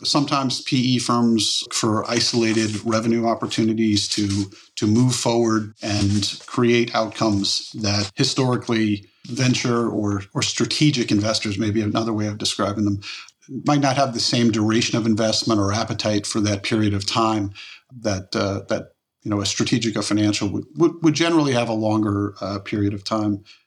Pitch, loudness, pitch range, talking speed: 110 Hz, -21 LUFS, 105-120 Hz, 155 wpm